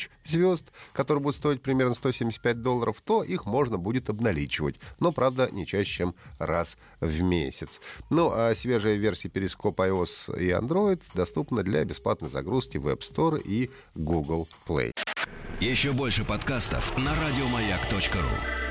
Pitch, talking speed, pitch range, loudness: 110 Hz, 140 wpm, 90-130 Hz, -28 LUFS